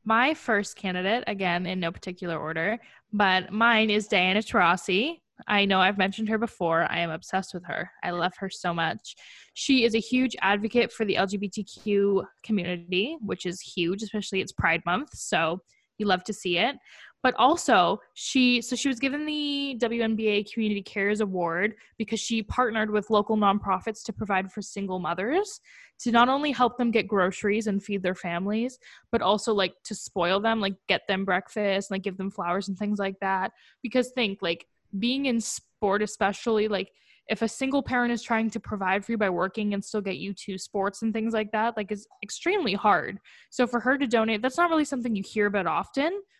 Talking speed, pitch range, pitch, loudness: 195 wpm, 190-230 Hz, 210 Hz, -26 LUFS